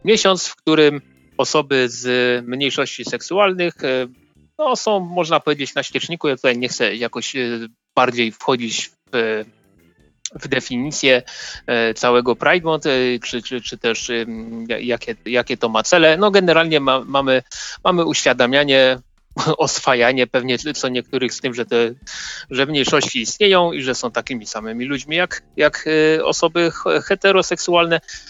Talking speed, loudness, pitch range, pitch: 130 wpm, -18 LUFS, 120-155 Hz, 130 Hz